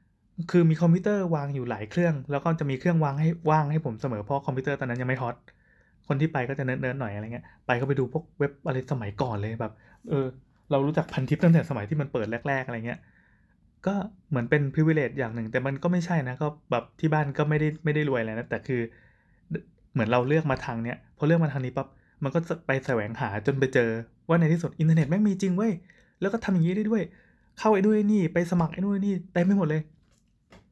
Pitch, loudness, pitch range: 145 Hz, -27 LUFS, 125-165 Hz